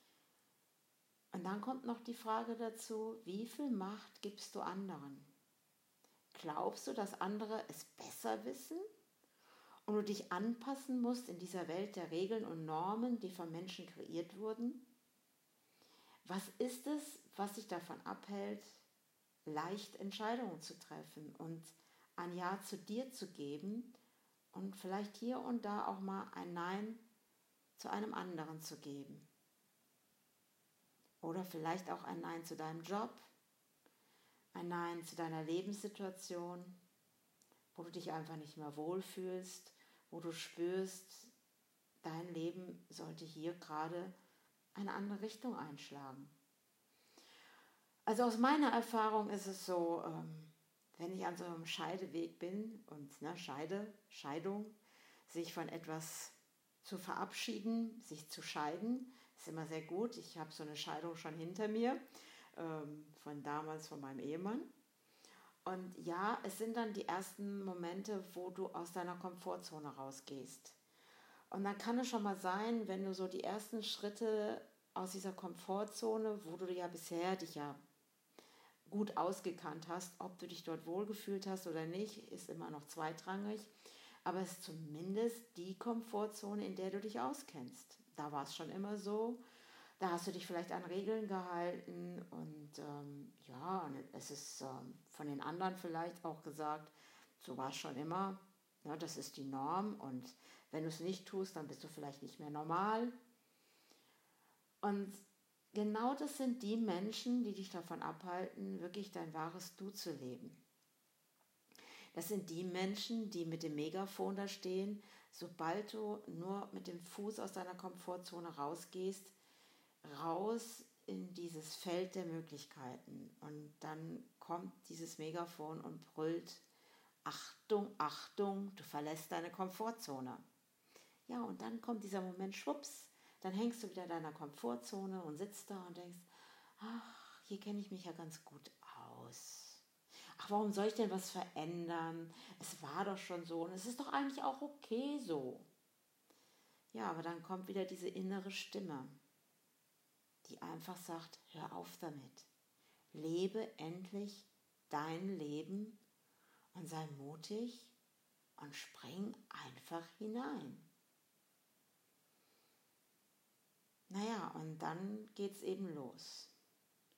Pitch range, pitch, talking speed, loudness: 165-210 Hz, 185 Hz, 140 wpm, -45 LUFS